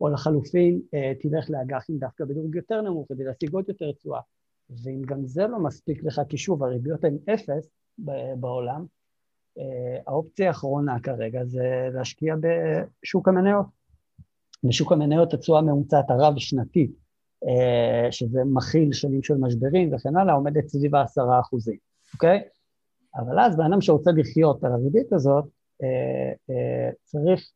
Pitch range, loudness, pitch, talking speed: 130-165 Hz, -24 LUFS, 145 Hz, 130 wpm